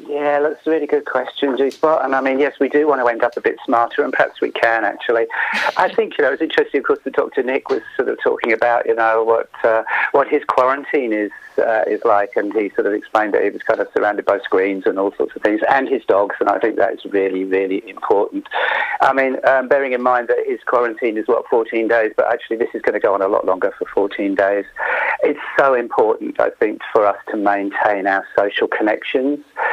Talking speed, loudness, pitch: 240 wpm, -17 LUFS, 140 Hz